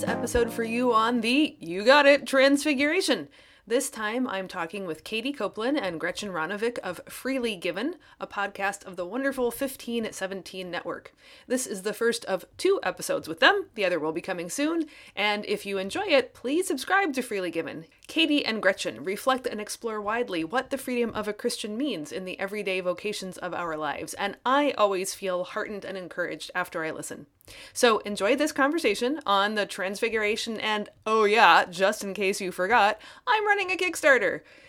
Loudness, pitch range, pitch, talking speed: -26 LUFS, 190-270 Hz, 220 Hz, 180 wpm